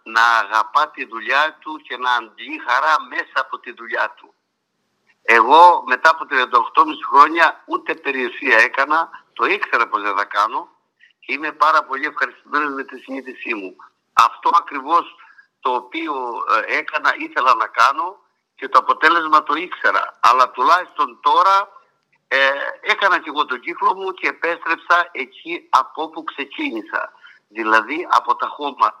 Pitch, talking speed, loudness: 175 Hz, 145 wpm, -17 LUFS